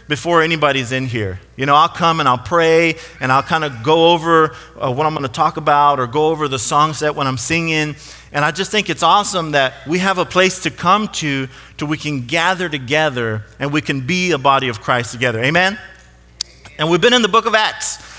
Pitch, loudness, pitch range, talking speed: 150 Hz, -15 LUFS, 135-165 Hz, 230 wpm